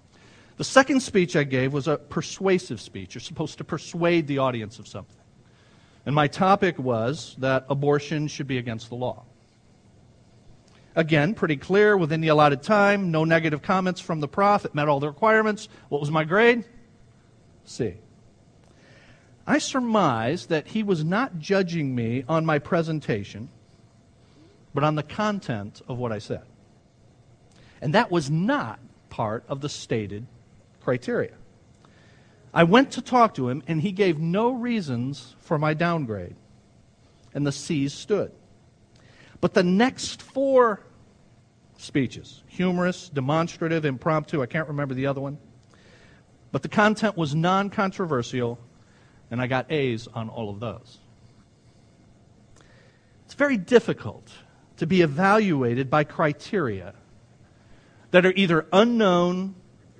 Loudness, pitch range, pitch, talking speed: -24 LUFS, 120-180 Hz, 145 Hz, 135 wpm